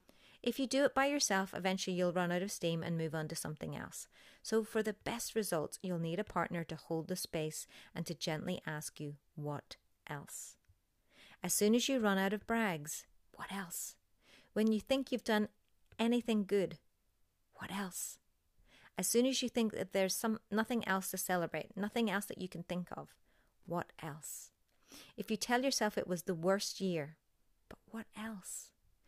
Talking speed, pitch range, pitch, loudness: 185 wpm, 165-220 Hz, 190 Hz, -37 LUFS